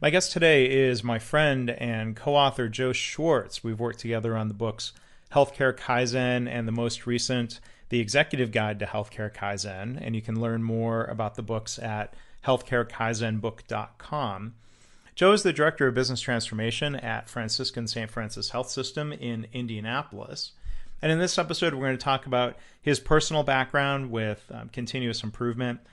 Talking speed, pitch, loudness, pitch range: 160 wpm, 120 Hz, -27 LUFS, 115-130 Hz